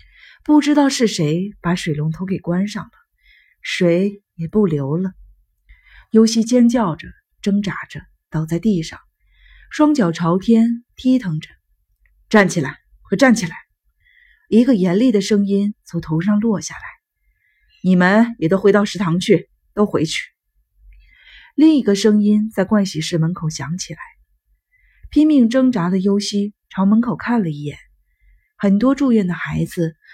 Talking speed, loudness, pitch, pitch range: 205 characters per minute, -17 LUFS, 200 Hz, 170-230 Hz